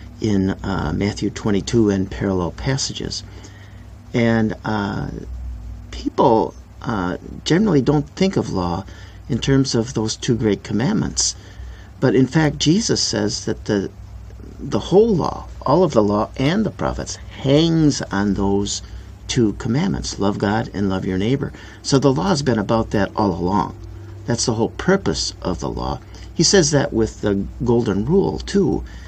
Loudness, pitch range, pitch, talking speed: -19 LUFS, 95-120 Hz, 105 Hz, 155 wpm